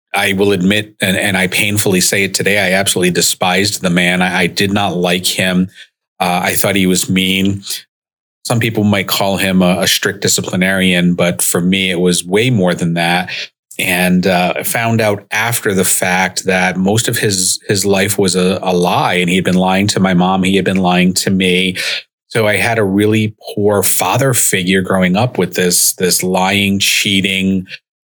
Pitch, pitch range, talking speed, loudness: 95 Hz, 90-100 Hz, 195 wpm, -12 LUFS